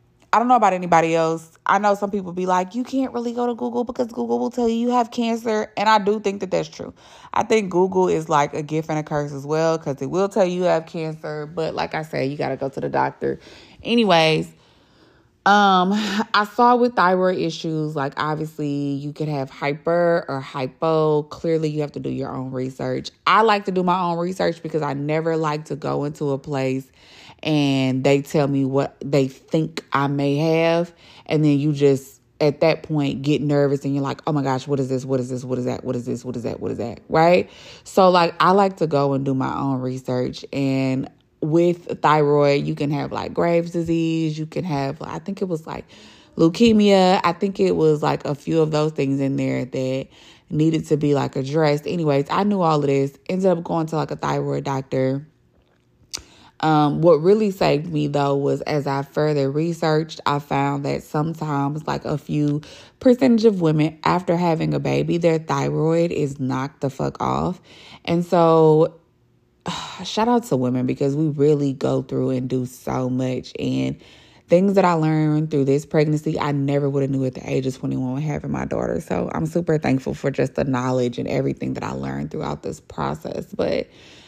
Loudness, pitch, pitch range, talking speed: -21 LUFS, 150 Hz, 135-170 Hz, 210 wpm